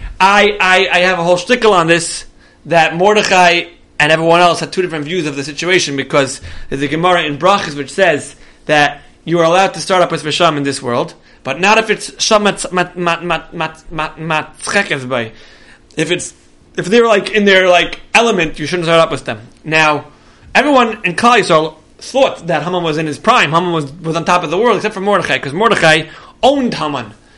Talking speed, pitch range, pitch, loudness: 190 wpm, 155-190 Hz, 170 Hz, -12 LUFS